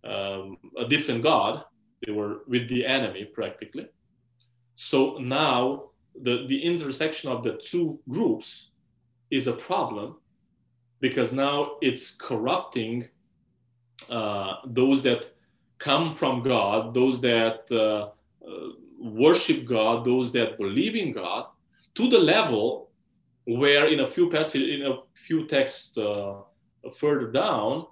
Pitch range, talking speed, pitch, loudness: 115-135 Hz, 125 wpm, 125 Hz, -25 LUFS